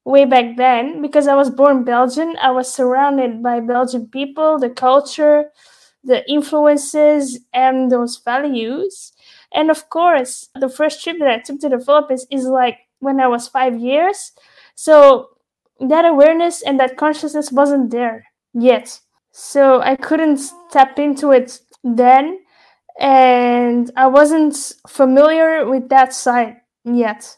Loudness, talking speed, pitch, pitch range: -14 LUFS, 140 wpm, 270 Hz, 250-295 Hz